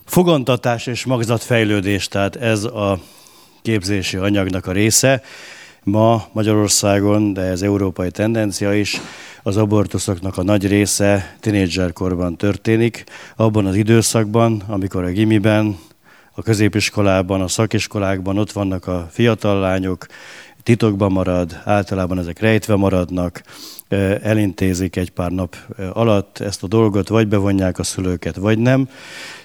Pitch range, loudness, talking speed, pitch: 95-110 Hz, -17 LUFS, 120 wpm, 100 Hz